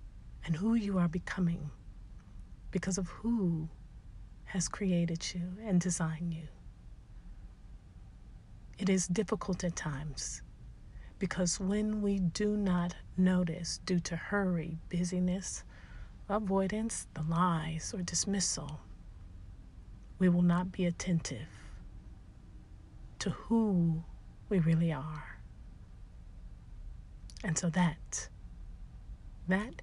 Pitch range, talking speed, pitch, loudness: 150-185 Hz, 95 wpm, 175 Hz, -34 LUFS